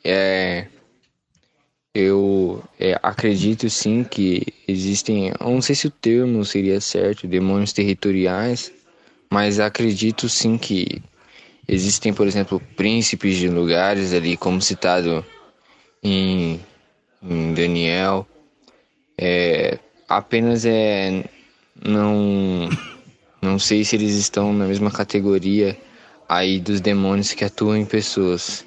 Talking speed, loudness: 105 wpm, -20 LUFS